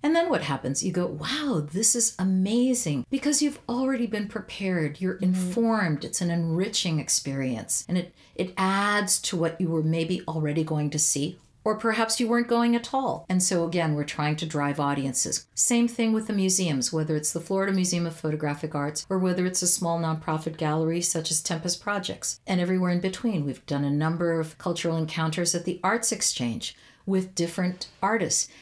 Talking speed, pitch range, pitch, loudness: 190 wpm, 160-205 Hz, 175 Hz, -26 LUFS